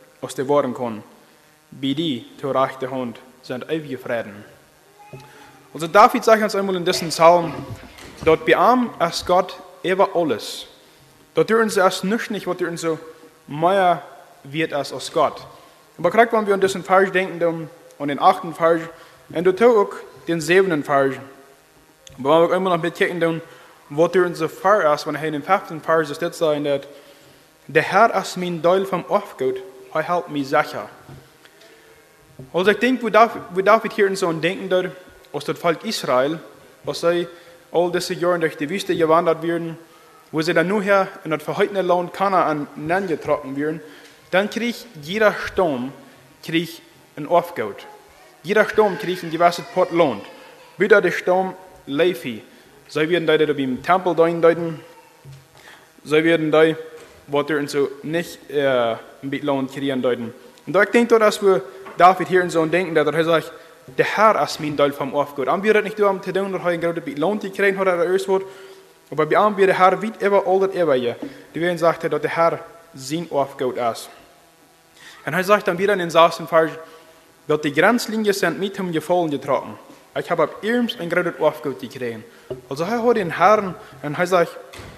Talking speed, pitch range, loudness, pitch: 175 wpm, 150-185 Hz, -19 LUFS, 165 Hz